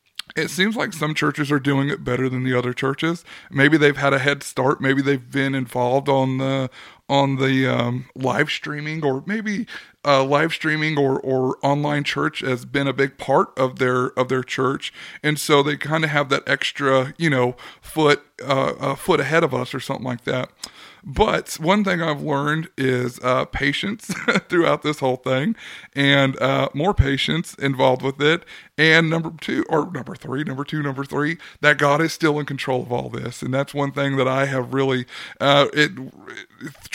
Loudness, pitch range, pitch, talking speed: -20 LUFS, 130-150 Hz, 140 Hz, 195 wpm